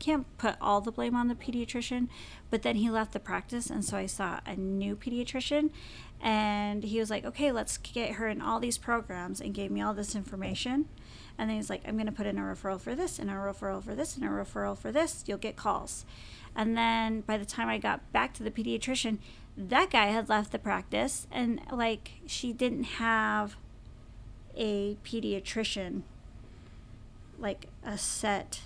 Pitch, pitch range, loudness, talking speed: 220 Hz, 195-240 Hz, -32 LUFS, 195 wpm